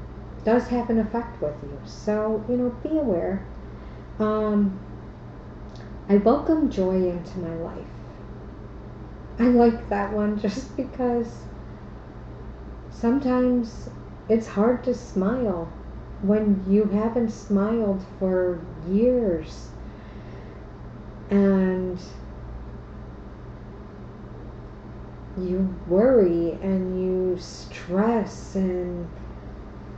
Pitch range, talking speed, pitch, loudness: 185-230 Hz, 85 wpm, 205 Hz, -24 LUFS